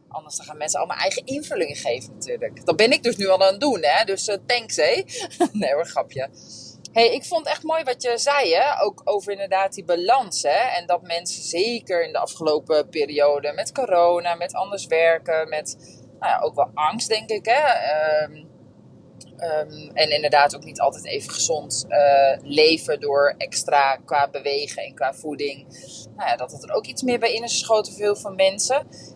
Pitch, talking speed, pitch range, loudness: 175 Hz, 200 wpm, 150-235 Hz, -21 LUFS